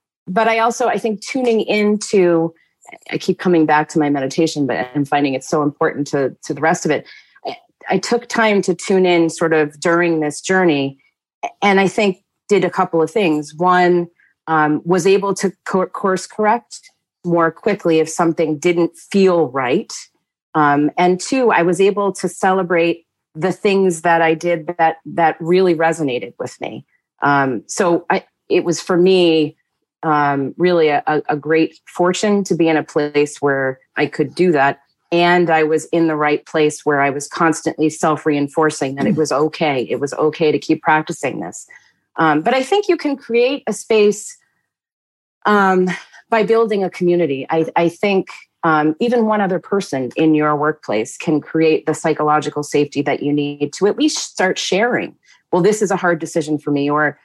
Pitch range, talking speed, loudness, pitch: 150-190 Hz, 180 wpm, -16 LUFS, 165 Hz